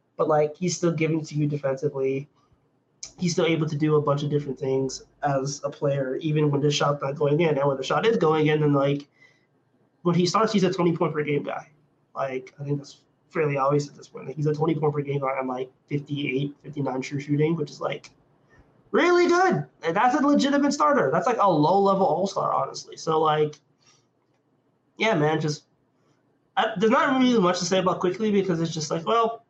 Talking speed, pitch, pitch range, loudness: 220 wpm, 150 Hz, 140-175 Hz, -24 LUFS